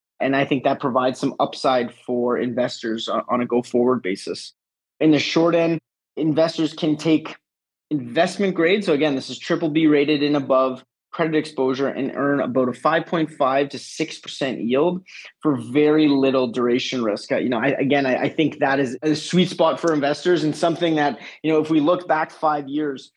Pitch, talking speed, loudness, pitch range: 145 Hz, 185 wpm, -21 LUFS, 130-160 Hz